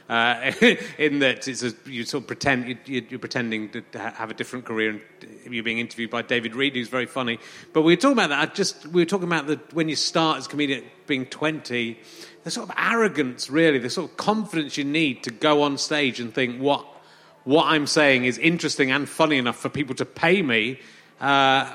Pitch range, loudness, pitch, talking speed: 120-155 Hz, -23 LUFS, 135 Hz, 225 wpm